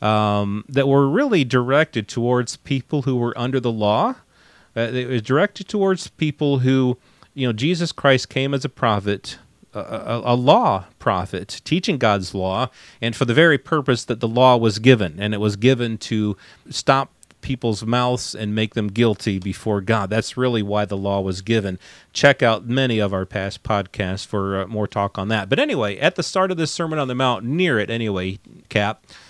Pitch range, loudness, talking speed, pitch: 105-135 Hz, -20 LUFS, 190 wpm, 120 Hz